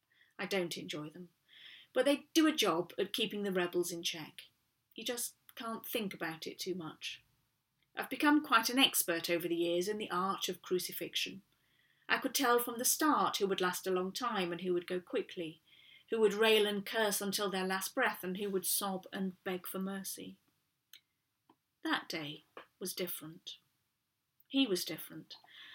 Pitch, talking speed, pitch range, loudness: 190 Hz, 180 wpm, 175-225 Hz, -35 LUFS